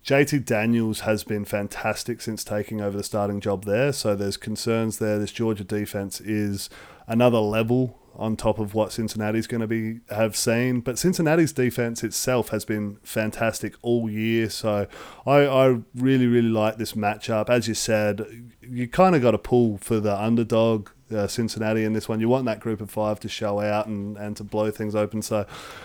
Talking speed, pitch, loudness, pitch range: 190 wpm, 110 Hz, -24 LUFS, 105-120 Hz